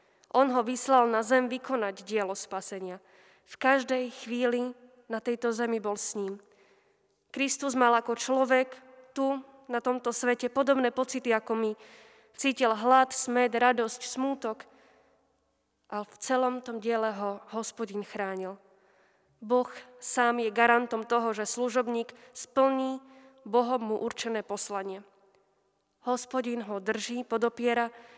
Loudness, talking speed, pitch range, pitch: -29 LUFS, 125 wpm, 220-255 Hz, 235 Hz